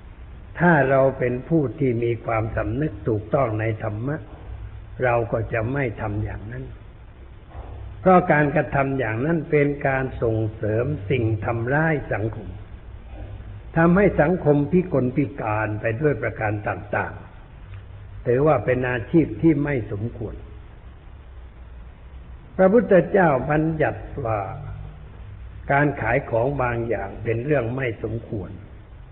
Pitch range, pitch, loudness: 105-140 Hz, 115 Hz, -22 LUFS